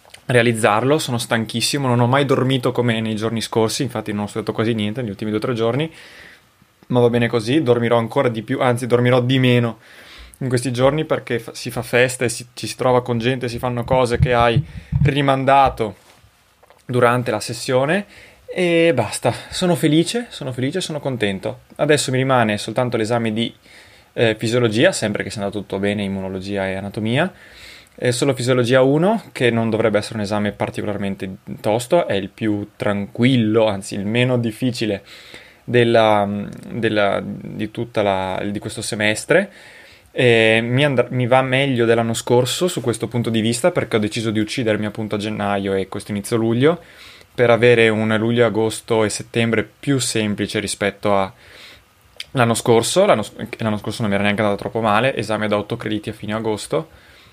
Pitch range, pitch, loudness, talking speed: 105-125 Hz, 115 Hz, -19 LUFS, 170 wpm